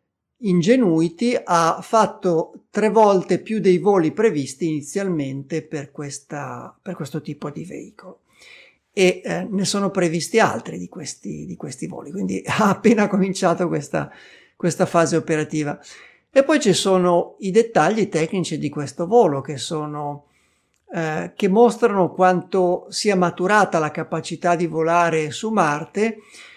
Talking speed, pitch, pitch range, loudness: 135 wpm, 180 Hz, 160-200 Hz, -20 LUFS